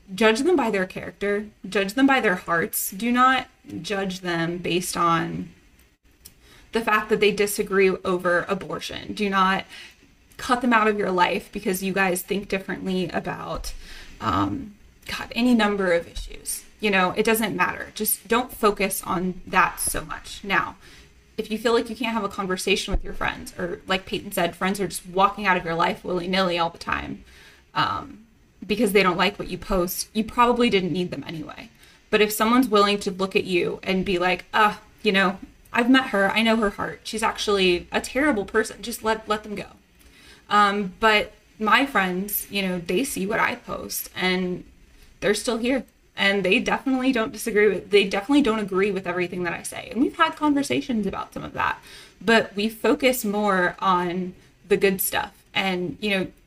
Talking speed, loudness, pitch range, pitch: 190 wpm, -23 LUFS, 185-220 Hz, 200 Hz